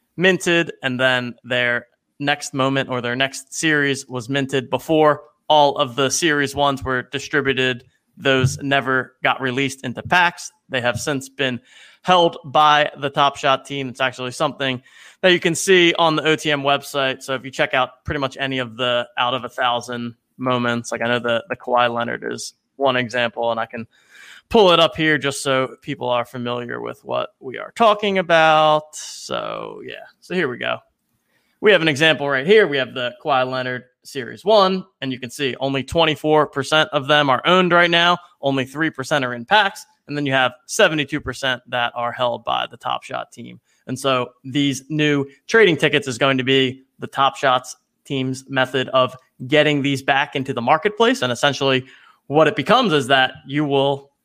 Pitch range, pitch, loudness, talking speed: 130-150 Hz, 135 Hz, -19 LUFS, 190 wpm